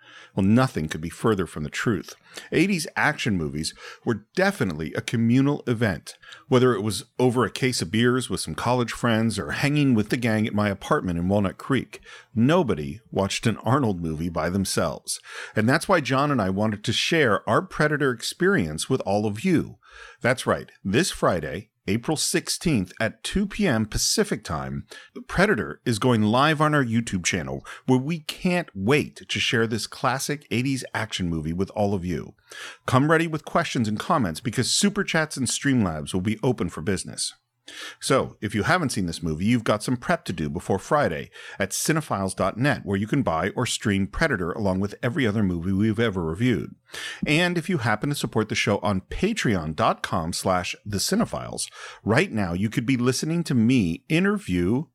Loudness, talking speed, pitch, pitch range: -24 LUFS, 180 wpm, 115 Hz, 95-135 Hz